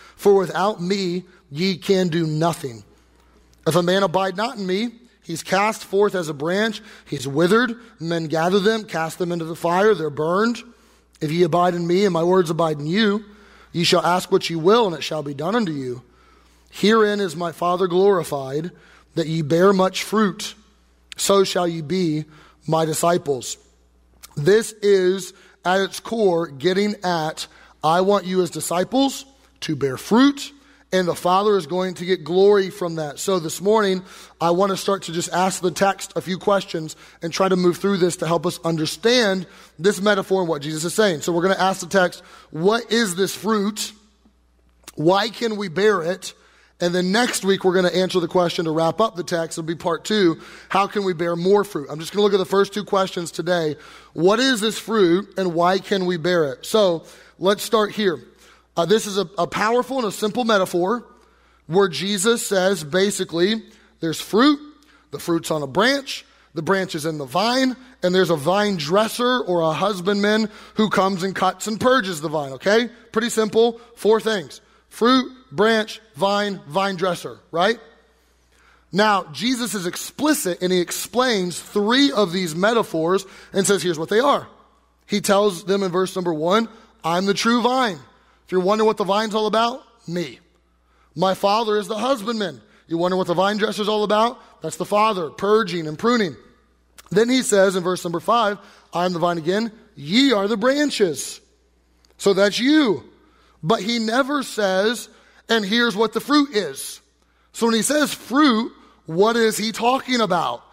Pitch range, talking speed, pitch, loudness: 170-215 Hz, 185 wpm, 190 Hz, -20 LUFS